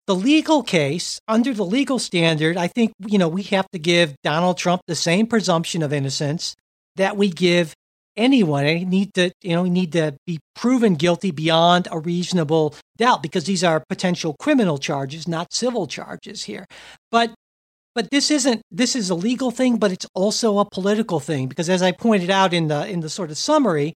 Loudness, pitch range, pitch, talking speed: -20 LUFS, 165-220 Hz, 185 Hz, 200 wpm